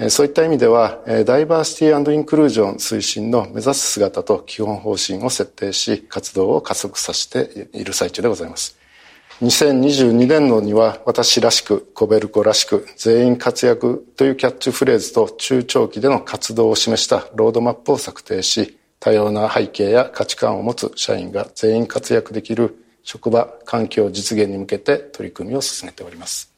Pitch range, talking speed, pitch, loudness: 110-145 Hz, 350 characters per minute, 120 Hz, -17 LUFS